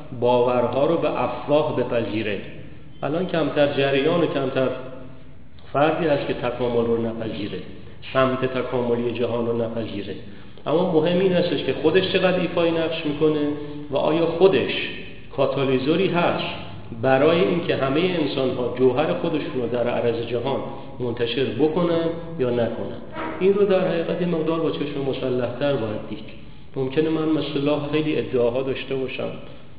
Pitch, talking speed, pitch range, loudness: 135 Hz, 140 wpm, 120-155 Hz, -22 LUFS